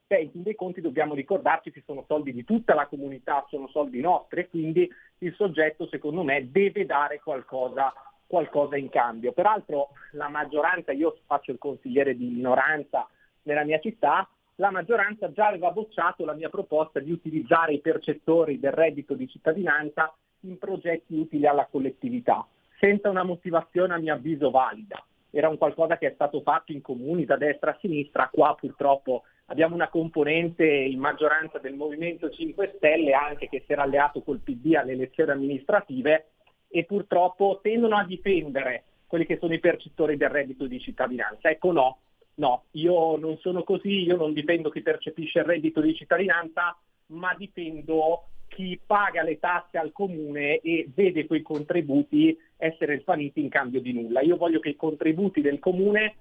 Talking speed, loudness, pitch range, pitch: 170 wpm, -26 LUFS, 145-175 Hz, 160 Hz